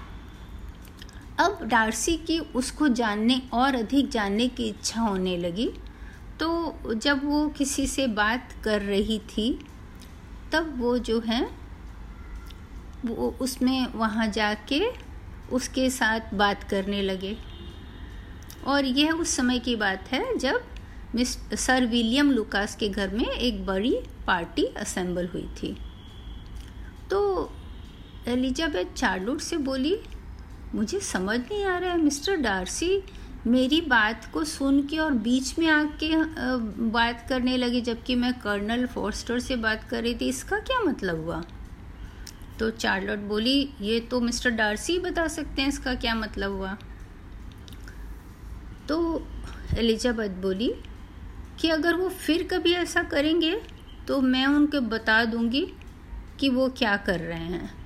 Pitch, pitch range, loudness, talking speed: 245 Hz, 205-290 Hz, -26 LUFS, 135 wpm